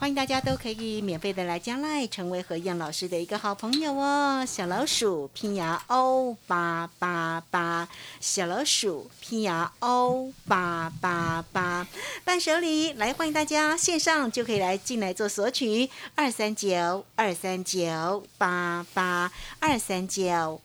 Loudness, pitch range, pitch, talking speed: -27 LUFS, 175-260 Hz, 200 Hz, 215 characters per minute